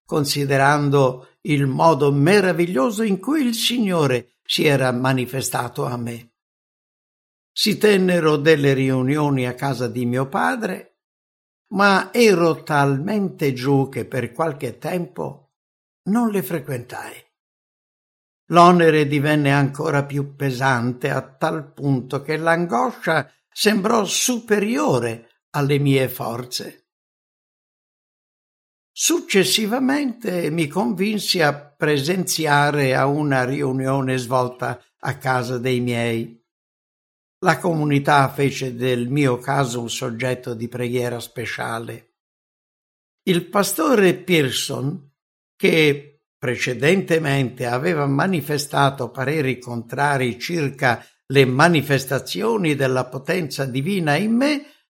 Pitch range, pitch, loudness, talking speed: 130-170 Hz, 140 Hz, -20 LUFS, 95 wpm